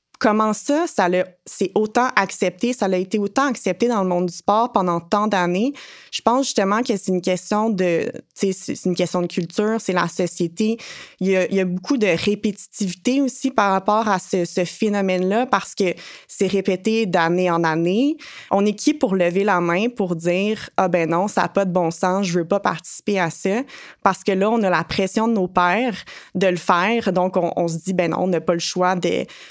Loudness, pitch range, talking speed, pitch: -20 LUFS, 180-215 Hz, 220 wpm, 195 Hz